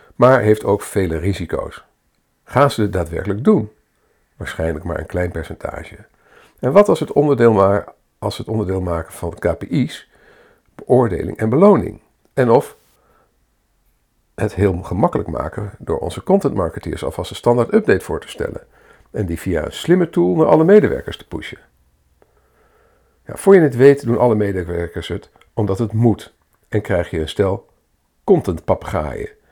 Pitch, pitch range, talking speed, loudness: 105 Hz, 85-135 Hz, 150 wpm, -17 LUFS